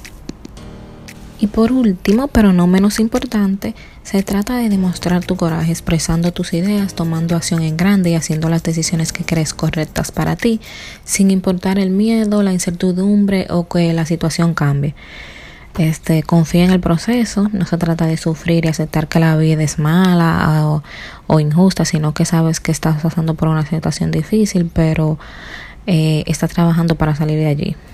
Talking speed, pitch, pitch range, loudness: 170 wpm, 170 Hz, 160-190 Hz, -15 LUFS